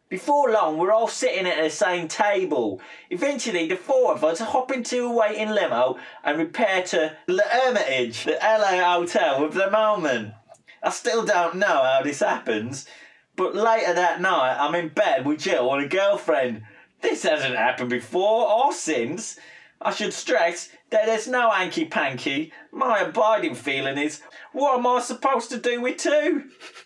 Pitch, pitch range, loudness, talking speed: 215 Hz, 160-255 Hz, -22 LUFS, 165 wpm